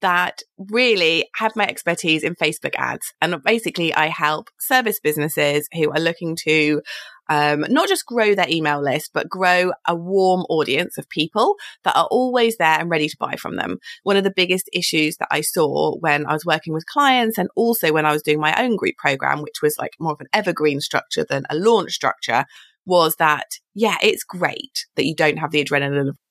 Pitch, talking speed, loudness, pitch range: 170 Hz, 205 wpm, -19 LUFS, 155-215 Hz